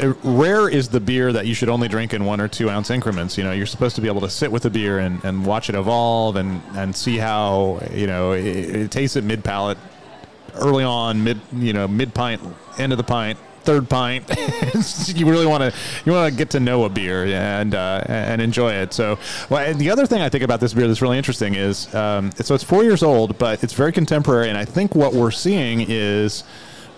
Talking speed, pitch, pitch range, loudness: 235 wpm, 115 Hz, 105-135 Hz, -19 LUFS